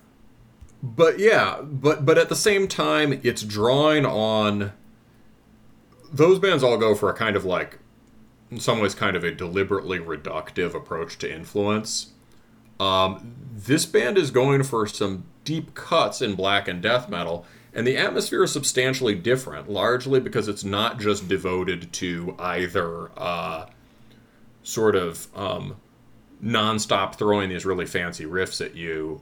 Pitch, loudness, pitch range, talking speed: 110 Hz, -23 LUFS, 95-130 Hz, 145 wpm